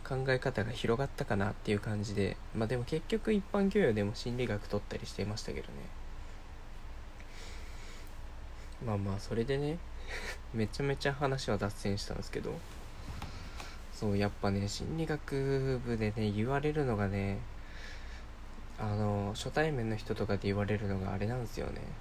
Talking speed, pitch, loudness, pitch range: 310 characters per minute, 105 Hz, -35 LUFS, 100-125 Hz